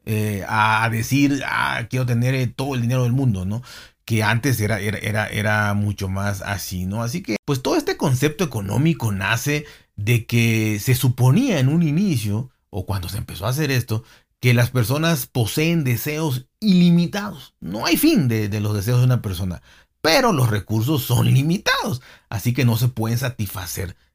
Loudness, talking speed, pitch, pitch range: -20 LUFS, 175 wpm, 120 Hz, 105-135 Hz